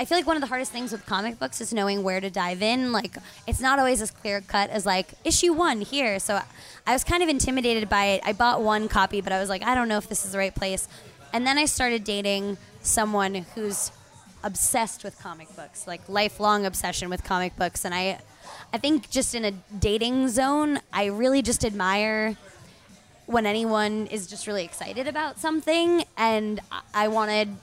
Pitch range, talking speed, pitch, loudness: 195-250 Hz, 205 wpm, 215 Hz, -25 LUFS